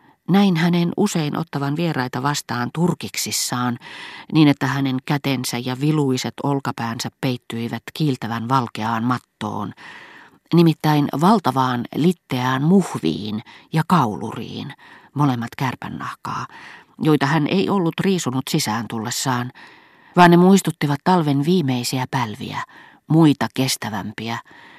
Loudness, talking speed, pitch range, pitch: -20 LUFS, 100 wpm, 120-160 Hz, 135 Hz